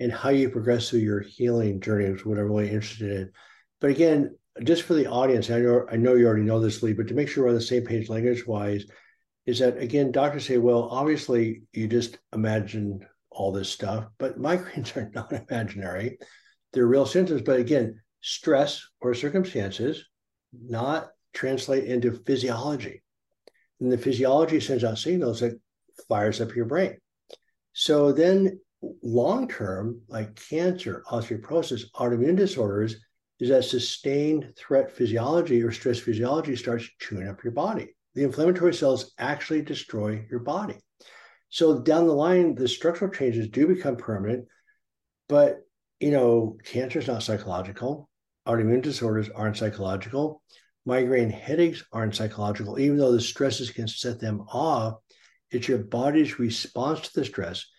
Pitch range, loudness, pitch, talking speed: 110-140 Hz, -25 LUFS, 120 Hz, 155 wpm